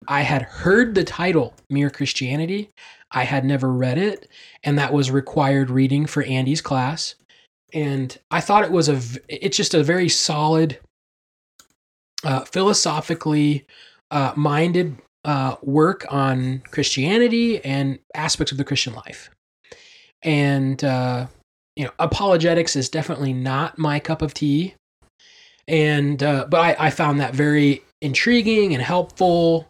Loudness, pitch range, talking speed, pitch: -20 LUFS, 135-170 Hz, 135 wpm, 150 Hz